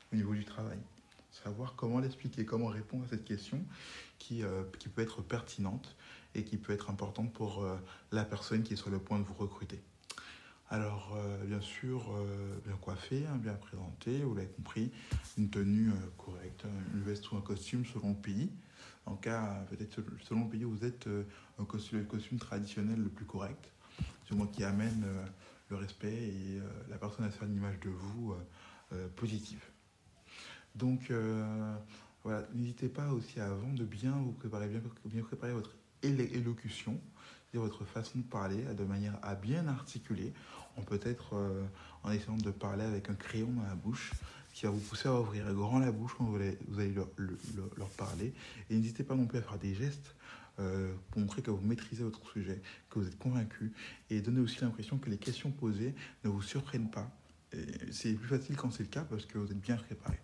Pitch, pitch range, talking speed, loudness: 105 Hz, 100-115 Hz, 205 wpm, -39 LUFS